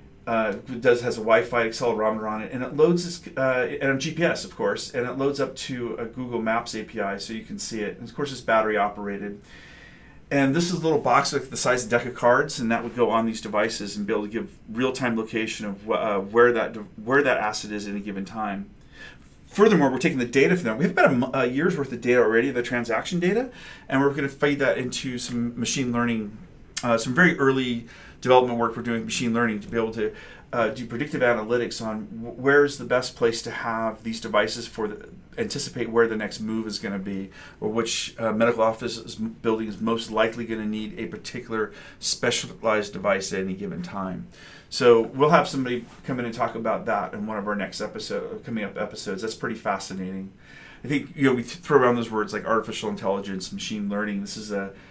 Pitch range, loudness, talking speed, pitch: 110-130 Hz, -25 LUFS, 230 wpm, 115 Hz